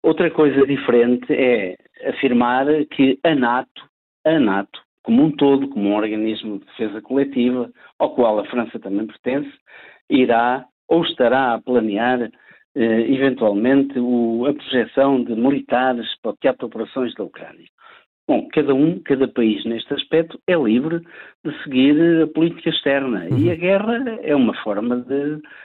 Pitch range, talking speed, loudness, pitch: 120-150 Hz, 155 wpm, -19 LUFS, 135 Hz